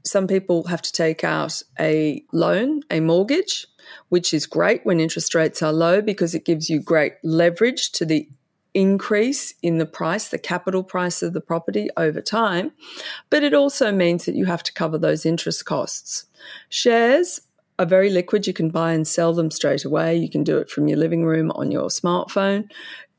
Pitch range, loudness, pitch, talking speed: 160-200 Hz, -20 LUFS, 170 Hz, 190 wpm